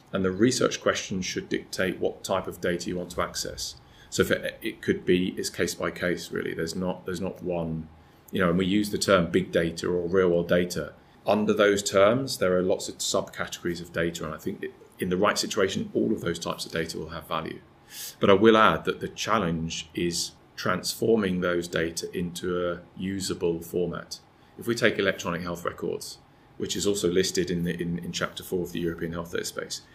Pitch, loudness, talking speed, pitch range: 90 Hz, -27 LUFS, 210 wpm, 85-95 Hz